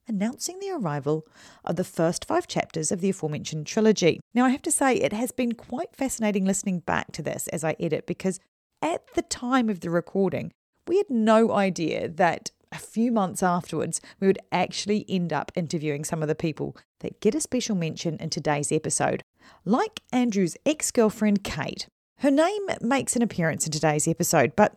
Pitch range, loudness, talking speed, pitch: 165-240 Hz, -26 LUFS, 185 wpm, 195 Hz